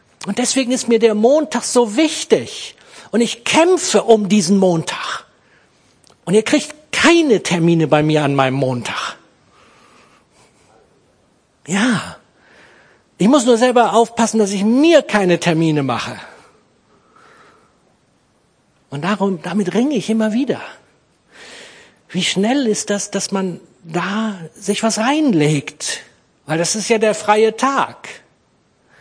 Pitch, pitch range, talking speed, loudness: 210 Hz, 175-240 Hz, 125 wpm, -16 LUFS